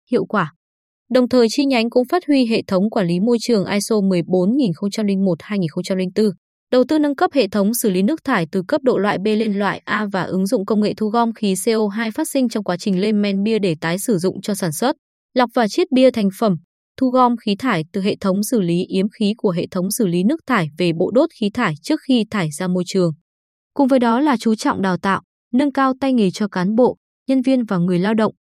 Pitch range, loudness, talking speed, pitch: 190-250 Hz, -18 LUFS, 245 wpm, 215 Hz